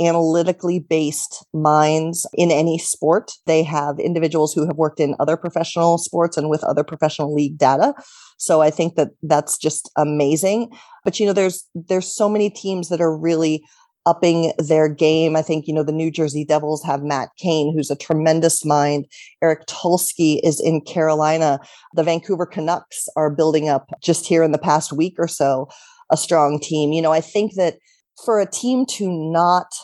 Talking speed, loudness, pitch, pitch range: 180 wpm, -19 LUFS, 160 Hz, 155-175 Hz